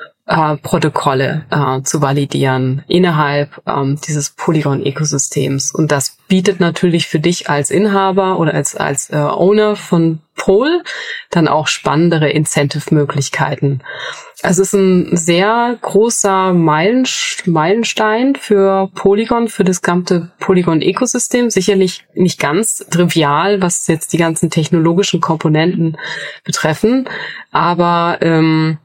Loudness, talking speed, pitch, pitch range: -14 LUFS, 115 wpm, 170 Hz, 155-195 Hz